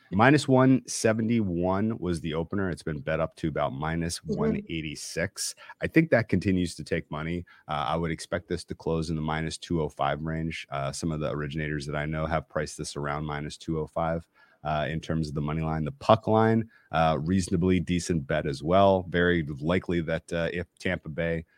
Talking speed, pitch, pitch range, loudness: 190 wpm, 85 Hz, 80-95 Hz, -28 LUFS